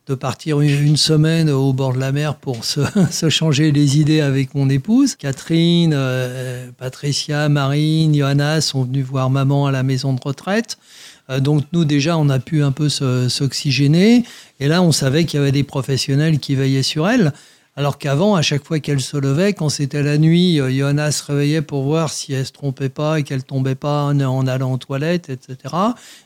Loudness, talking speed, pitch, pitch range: -17 LUFS, 200 wpm, 145 Hz, 135-155 Hz